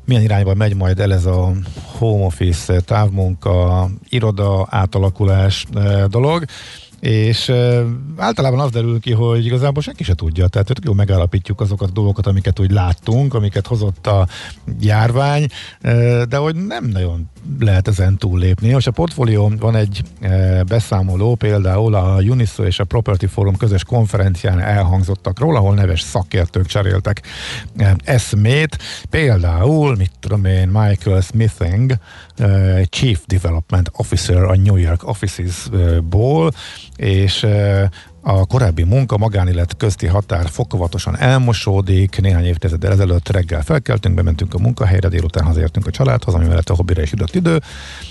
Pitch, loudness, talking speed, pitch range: 100 Hz, -16 LUFS, 135 wpm, 95-115 Hz